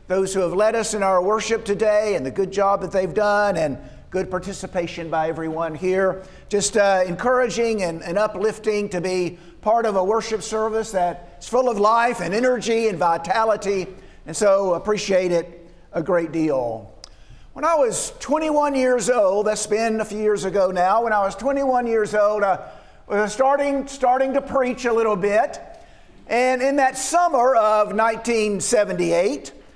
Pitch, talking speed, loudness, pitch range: 210 Hz, 170 wpm, -21 LUFS, 185-230 Hz